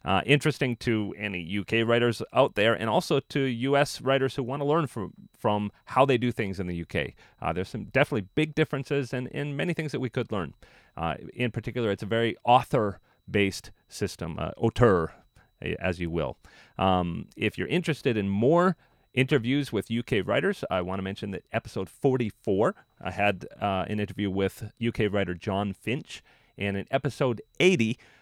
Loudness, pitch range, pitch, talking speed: -27 LUFS, 100-135 Hz, 115 Hz, 185 wpm